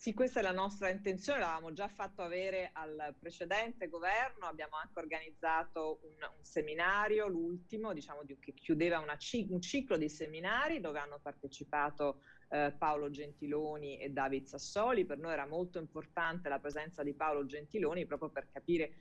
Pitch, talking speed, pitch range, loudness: 160 Hz, 160 wpm, 145-185 Hz, -38 LUFS